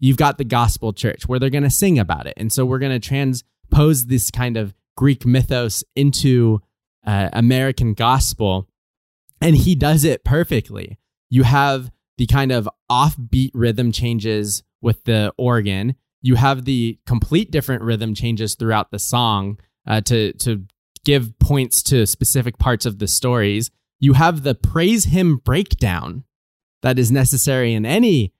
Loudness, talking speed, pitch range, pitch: -18 LUFS, 160 wpm, 110-135 Hz, 125 Hz